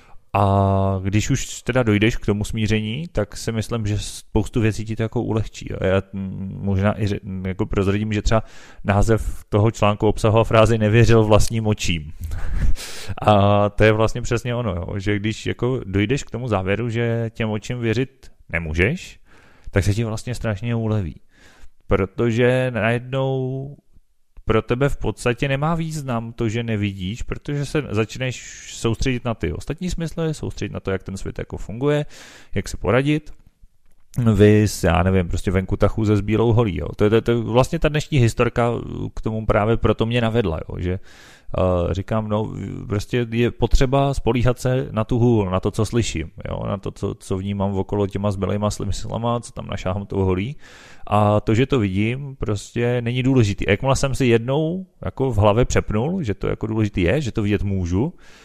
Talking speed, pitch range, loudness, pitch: 180 wpm, 100-120 Hz, -21 LUFS, 110 Hz